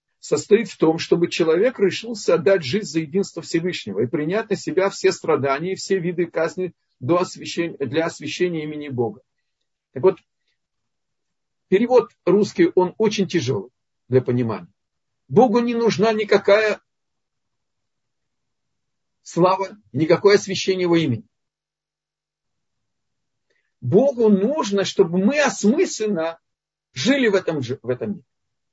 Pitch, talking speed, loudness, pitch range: 185 Hz, 115 wpm, -20 LUFS, 160-205 Hz